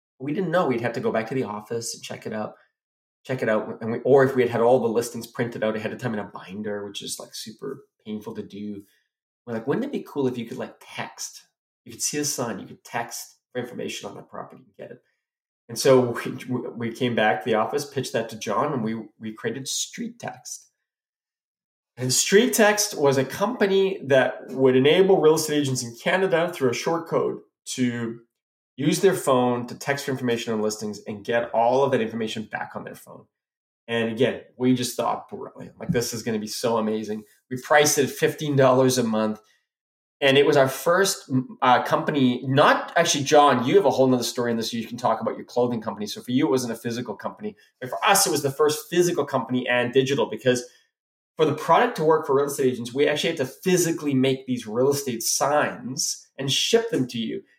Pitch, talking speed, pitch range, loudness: 130 Hz, 225 wpm, 115-150 Hz, -23 LUFS